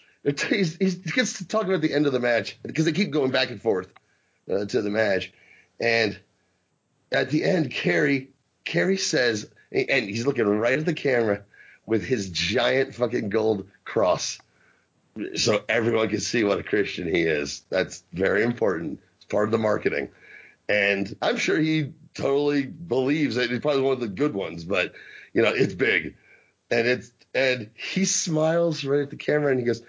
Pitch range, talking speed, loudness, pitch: 115-155 Hz, 180 wpm, -24 LUFS, 135 Hz